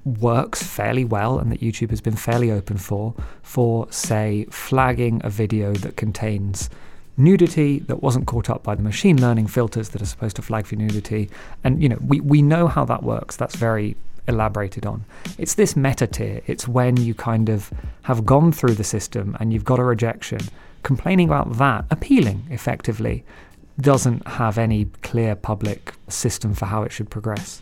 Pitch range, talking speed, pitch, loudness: 105-130 Hz, 180 wpm, 115 Hz, -21 LUFS